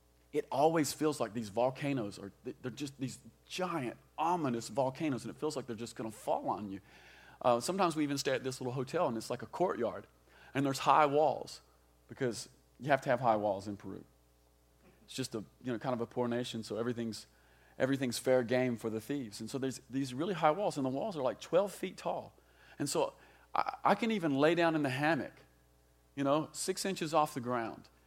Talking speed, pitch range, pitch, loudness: 215 wpm, 105-140 Hz, 125 Hz, -35 LUFS